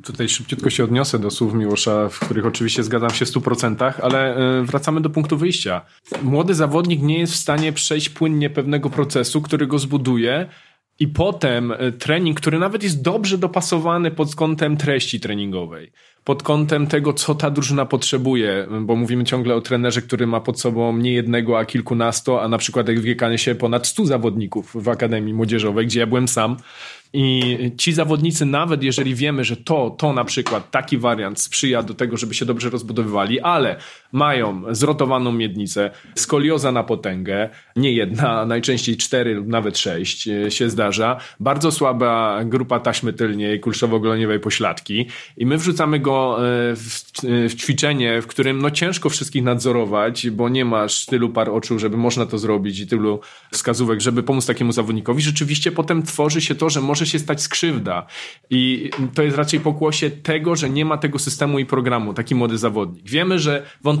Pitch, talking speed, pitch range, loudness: 125 Hz, 170 wpm, 115-150 Hz, -19 LUFS